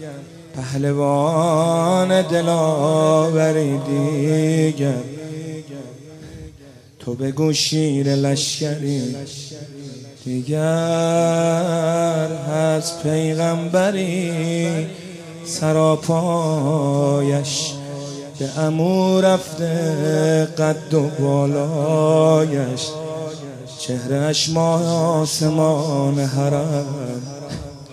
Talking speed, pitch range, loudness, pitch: 45 wpm, 140-160 Hz, -19 LUFS, 155 Hz